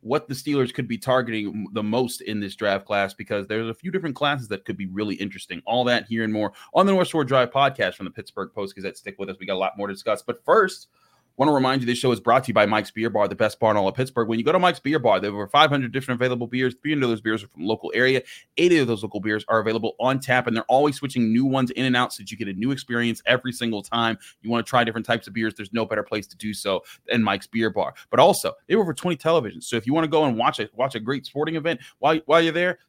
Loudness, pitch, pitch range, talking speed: -23 LUFS, 120 Hz, 110-135 Hz, 310 wpm